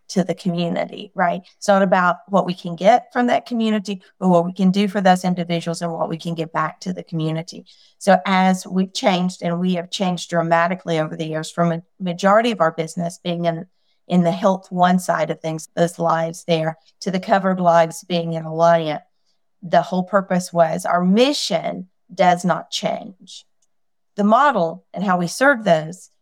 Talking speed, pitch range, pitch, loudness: 190 wpm, 170-200 Hz, 180 Hz, -19 LUFS